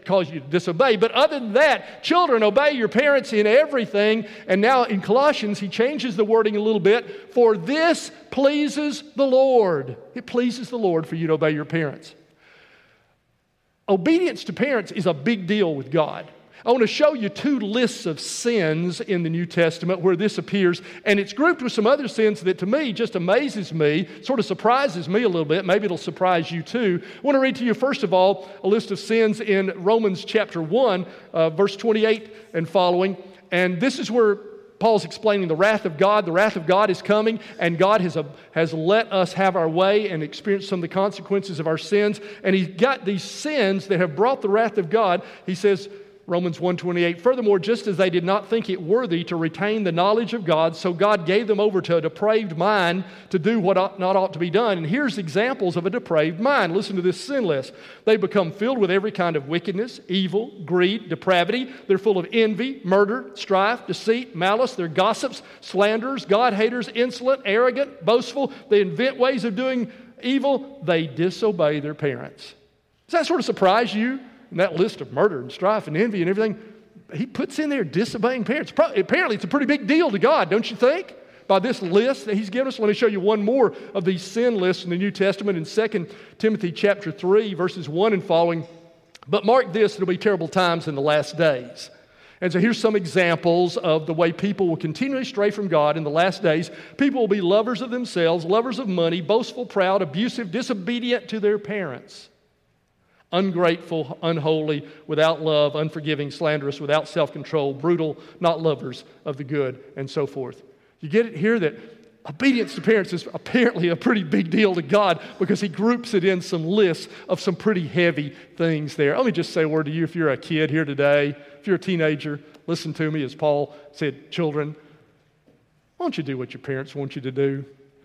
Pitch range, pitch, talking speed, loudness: 170-225 Hz, 195 Hz, 205 wpm, -21 LUFS